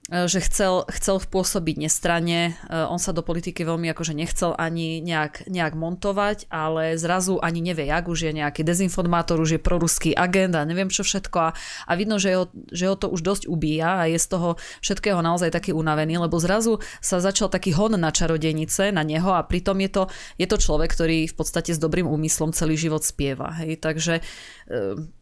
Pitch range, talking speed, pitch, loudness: 160-185 Hz, 190 wpm, 170 Hz, -23 LUFS